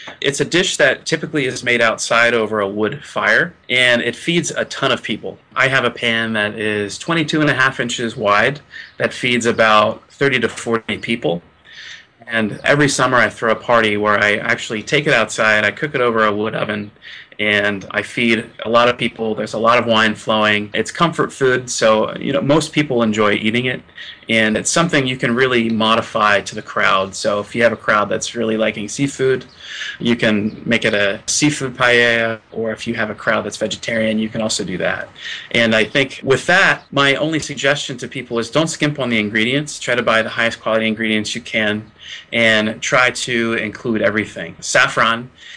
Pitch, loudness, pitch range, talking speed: 115 Hz, -16 LUFS, 110-130 Hz, 200 wpm